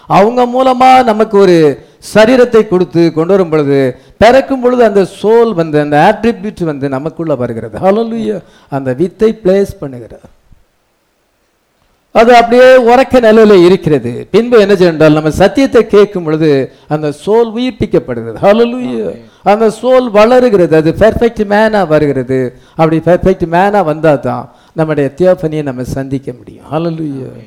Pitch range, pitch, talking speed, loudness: 150-220 Hz, 185 Hz, 125 wpm, -9 LUFS